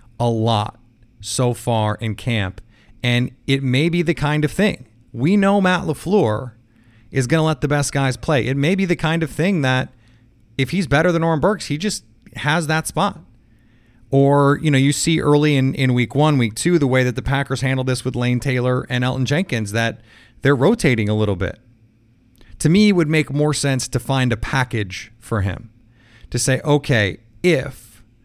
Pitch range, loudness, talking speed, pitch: 115-150 Hz, -19 LUFS, 200 wpm, 130 Hz